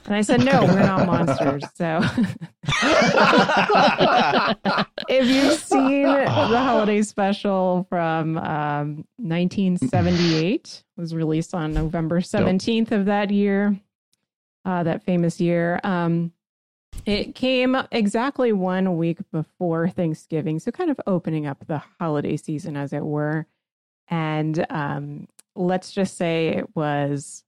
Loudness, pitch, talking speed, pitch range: -21 LUFS, 180 Hz, 120 wpm, 160-205 Hz